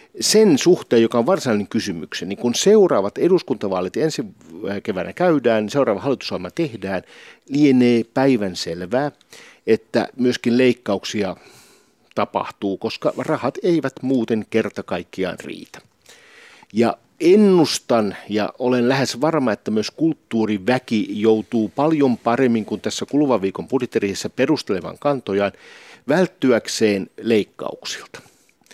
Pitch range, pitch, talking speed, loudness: 110-150 Hz, 125 Hz, 105 wpm, -19 LUFS